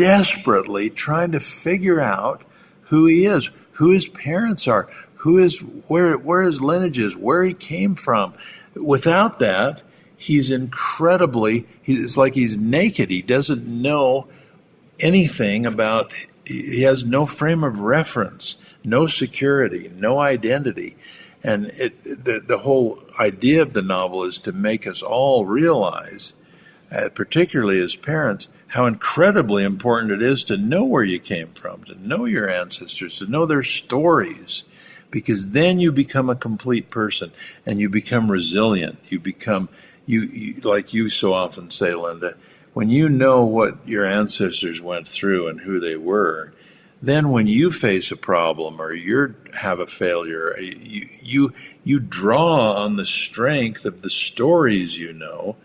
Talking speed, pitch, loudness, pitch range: 150 wpm, 125 Hz, -19 LUFS, 105-160 Hz